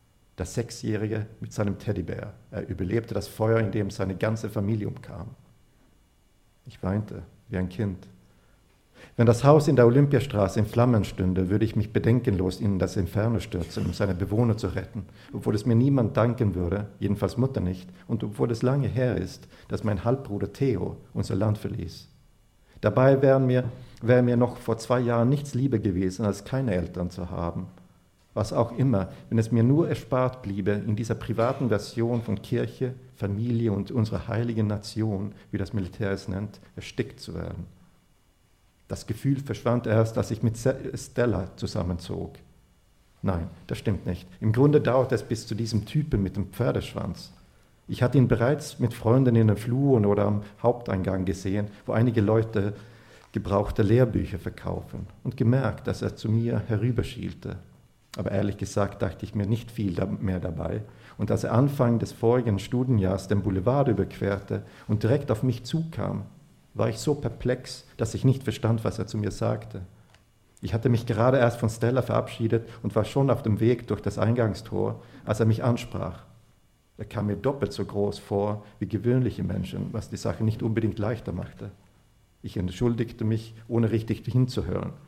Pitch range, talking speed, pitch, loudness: 100-120 Hz, 170 wpm, 110 Hz, -26 LUFS